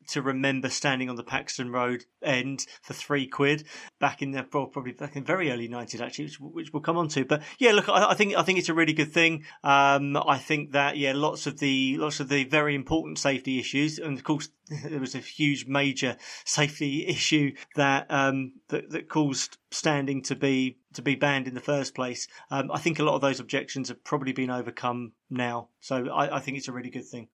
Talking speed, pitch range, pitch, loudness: 220 wpm, 130-150 Hz, 140 Hz, -27 LUFS